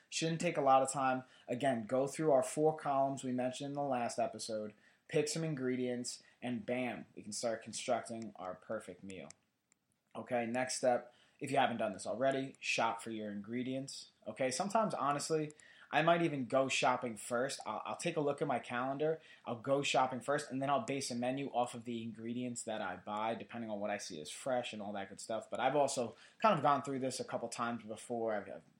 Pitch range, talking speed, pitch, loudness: 115-140 Hz, 215 wpm, 125 Hz, -37 LUFS